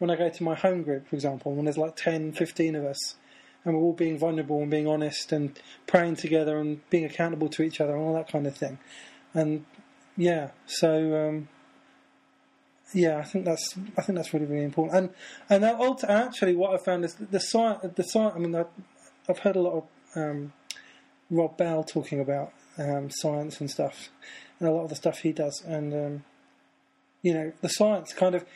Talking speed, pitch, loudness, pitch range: 210 wpm, 160 Hz, -28 LUFS, 150-185 Hz